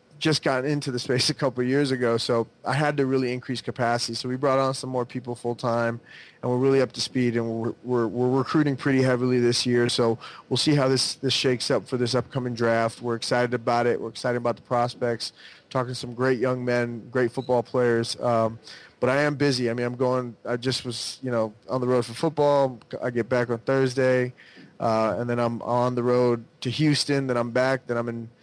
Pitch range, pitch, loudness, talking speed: 120-130 Hz, 125 Hz, -25 LUFS, 235 wpm